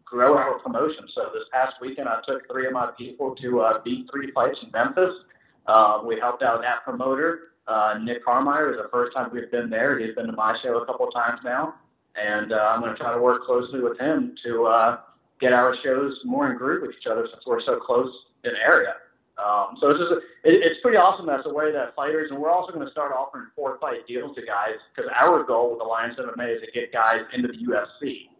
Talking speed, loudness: 240 wpm, -23 LUFS